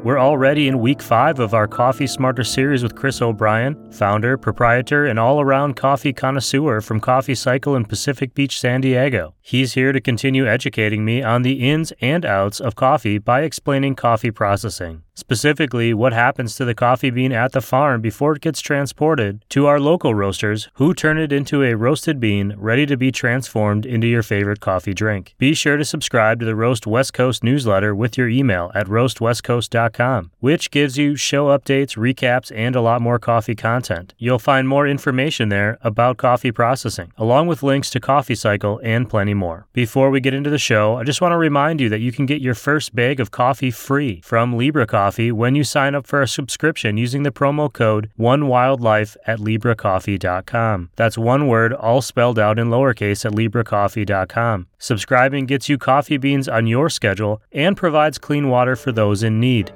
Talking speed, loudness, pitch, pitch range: 190 wpm, -18 LUFS, 125 Hz, 110-140 Hz